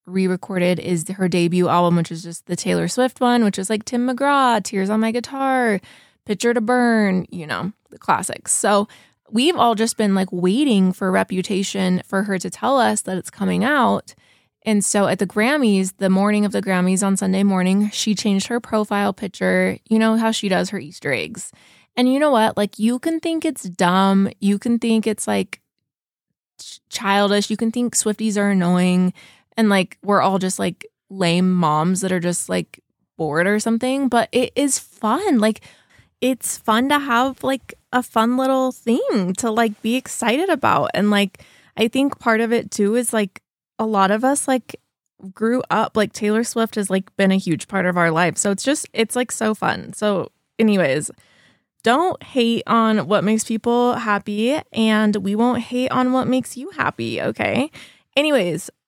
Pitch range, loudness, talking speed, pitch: 190-235 Hz, -19 LUFS, 190 wpm, 210 Hz